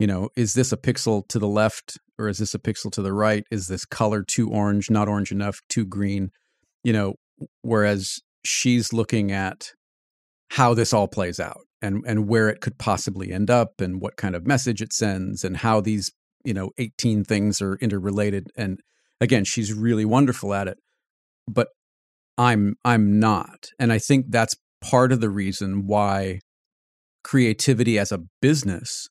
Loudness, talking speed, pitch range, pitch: -23 LUFS, 175 wpm, 100-115 Hz, 105 Hz